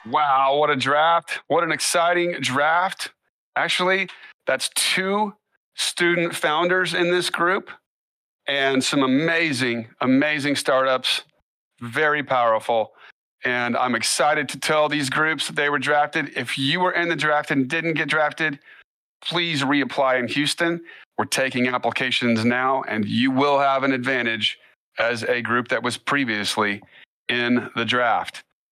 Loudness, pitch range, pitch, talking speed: -21 LUFS, 130-165 Hz, 140 Hz, 140 wpm